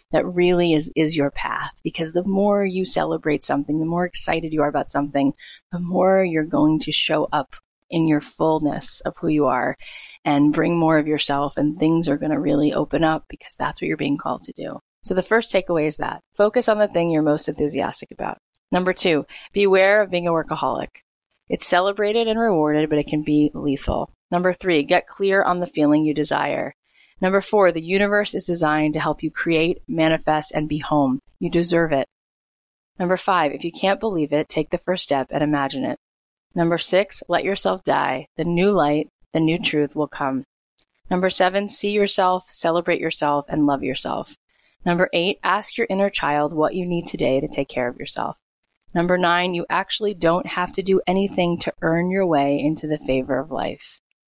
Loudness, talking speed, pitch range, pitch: -21 LUFS, 200 wpm, 150-185 Hz, 165 Hz